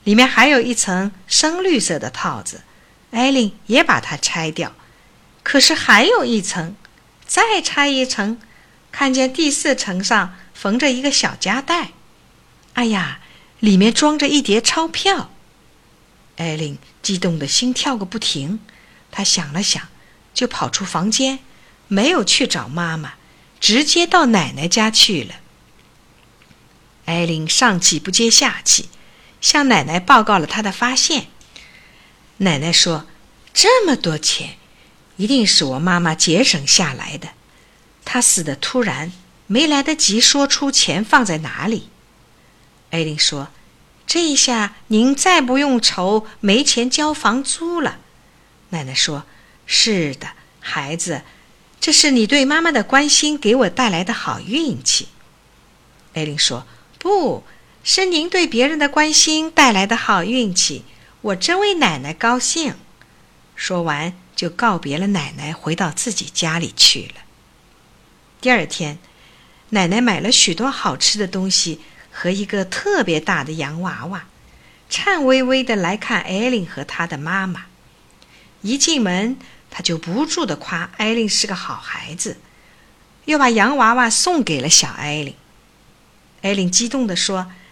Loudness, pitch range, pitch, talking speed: -16 LUFS, 175-265 Hz, 215 Hz, 200 characters per minute